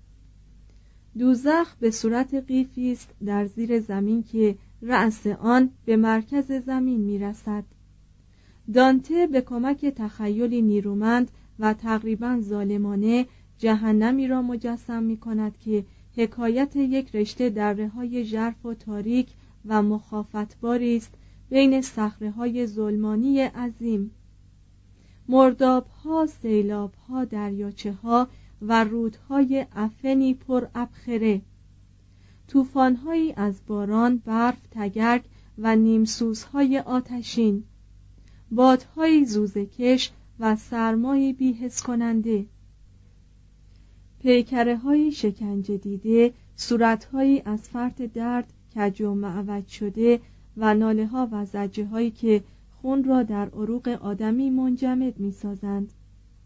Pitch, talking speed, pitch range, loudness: 225 Hz, 105 wpm, 205-250 Hz, -24 LUFS